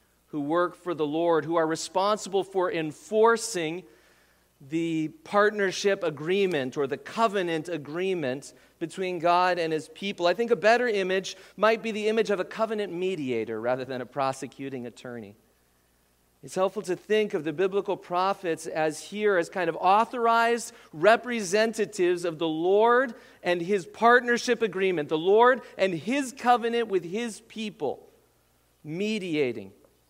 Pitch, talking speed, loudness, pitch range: 185 Hz, 140 wpm, -26 LUFS, 155-215 Hz